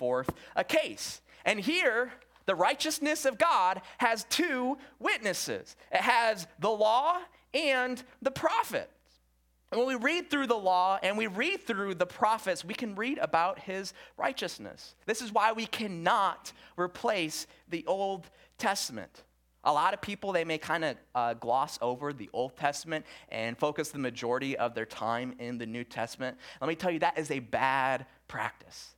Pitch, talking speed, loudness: 190 Hz, 165 wpm, -31 LUFS